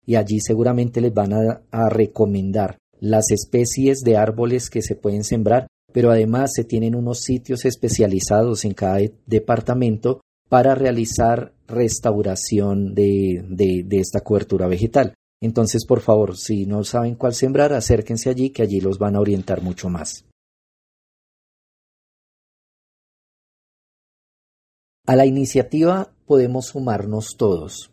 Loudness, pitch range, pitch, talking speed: -19 LUFS, 105-120 Hz, 115 Hz, 125 wpm